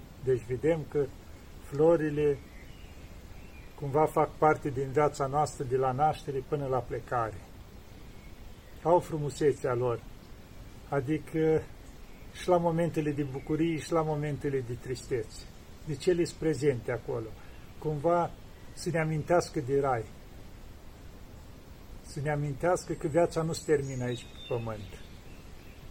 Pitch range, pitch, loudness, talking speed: 125-160 Hz, 145 Hz, -30 LUFS, 125 wpm